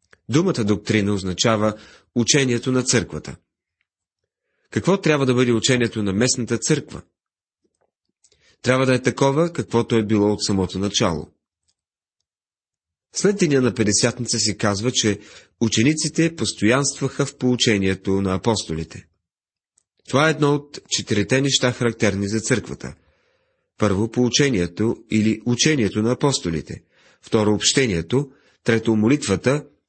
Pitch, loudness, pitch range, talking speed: 115 Hz, -20 LUFS, 100-130 Hz, 110 wpm